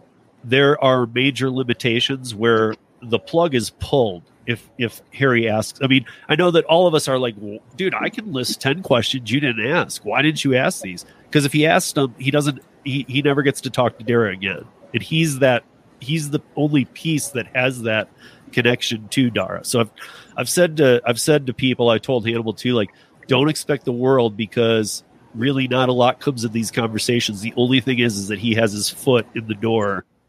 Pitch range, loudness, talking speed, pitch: 115-140 Hz, -19 LUFS, 210 wpm, 125 Hz